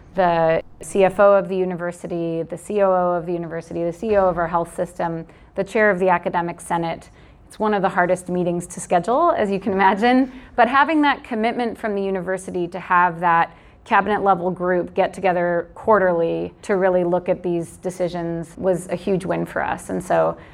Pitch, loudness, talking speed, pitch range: 180 Hz, -20 LUFS, 180 wpm, 170-195 Hz